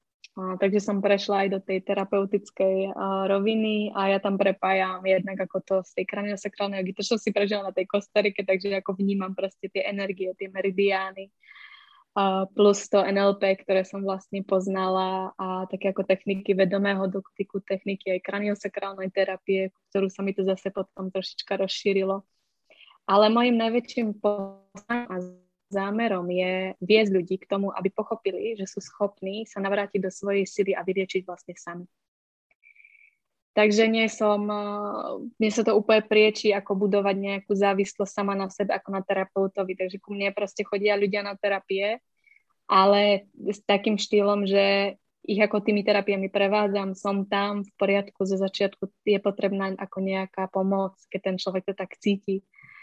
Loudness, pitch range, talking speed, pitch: -26 LUFS, 190-205 Hz, 155 wpm, 195 Hz